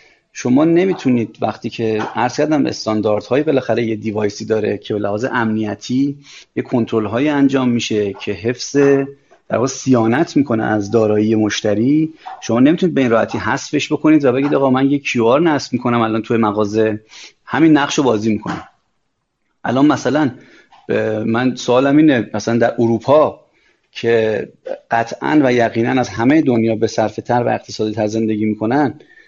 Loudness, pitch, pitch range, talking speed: -16 LUFS, 115 Hz, 110-135 Hz, 150 wpm